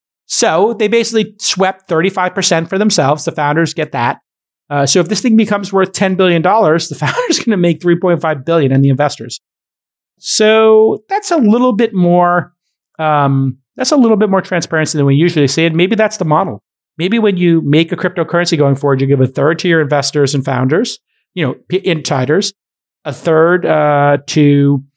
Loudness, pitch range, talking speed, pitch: -12 LUFS, 145-195 Hz, 200 wpm, 170 Hz